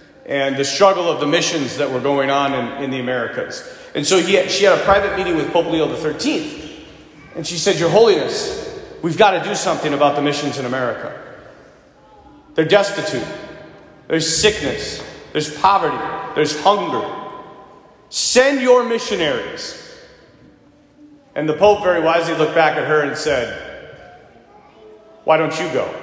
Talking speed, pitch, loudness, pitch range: 155 wpm, 185 Hz, -17 LUFS, 155-235 Hz